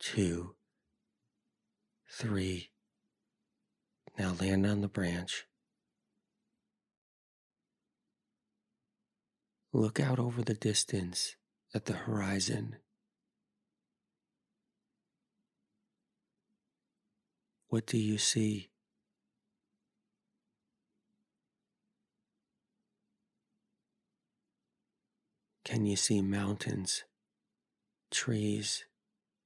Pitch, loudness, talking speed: 120 Hz, -34 LUFS, 50 wpm